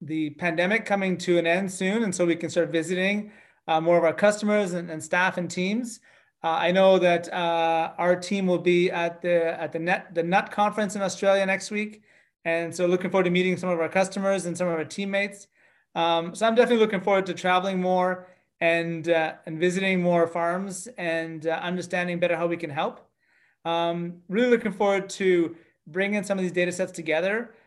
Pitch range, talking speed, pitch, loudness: 170-195 Hz, 205 wpm, 180 Hz, -25 LUFS